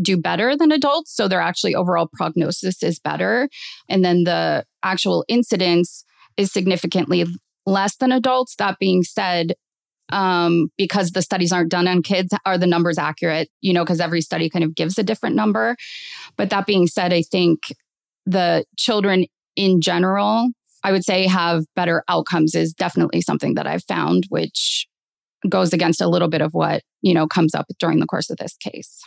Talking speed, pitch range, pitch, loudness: 180 wpm, 175-200 Hz, 185 Hz, -19 LUFS